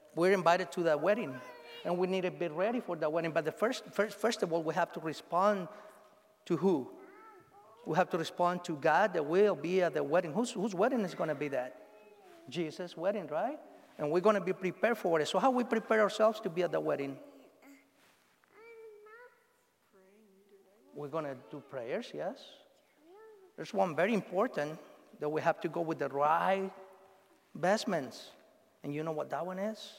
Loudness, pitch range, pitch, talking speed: -33 LUFS, 170-235 Hz, 195 Hz, 190 wpm